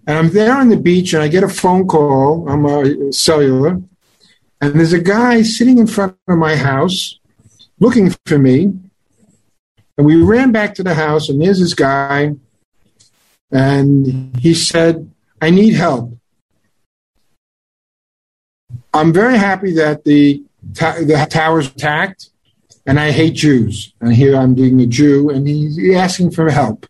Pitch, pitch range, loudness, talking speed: 155 Hz, 135-180 Hz, -12 LUFS, 155 wpm